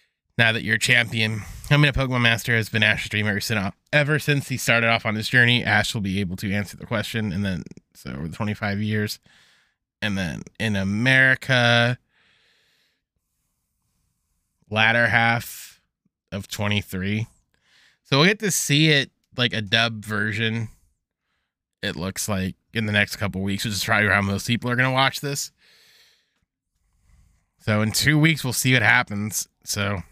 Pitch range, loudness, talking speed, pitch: 100-120 Hz, -21 LUFS, 170 wpm, 110 Hz